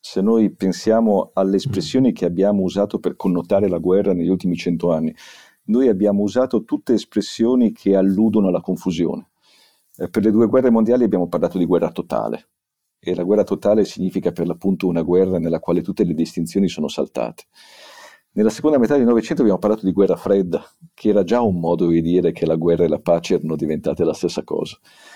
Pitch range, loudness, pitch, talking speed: 85-110 Hz, -19 LUFS, 95 Hz, 190 wpm